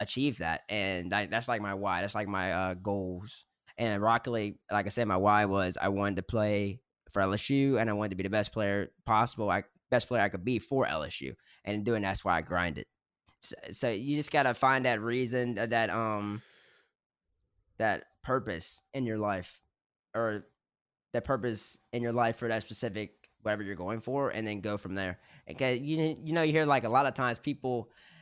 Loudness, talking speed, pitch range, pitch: -31 LUFS, 205 wpm, 100-125 Hz, 110 Hz